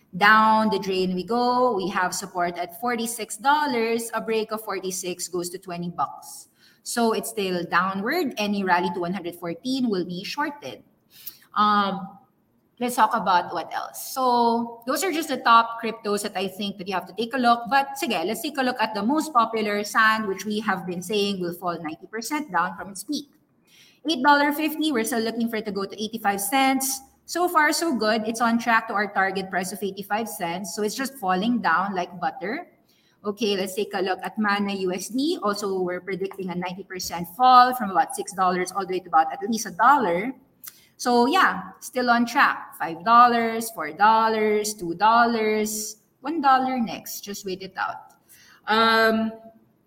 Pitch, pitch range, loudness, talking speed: 215 Hz, 190-240 Hz, -23 LUFS, 180 wpm